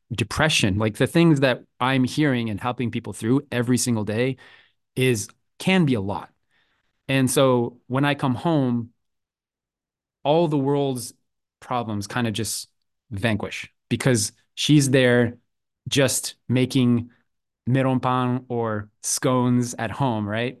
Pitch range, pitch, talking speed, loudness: 115-130 Hz, 125 Hz, 130 wpm, -22 LUFS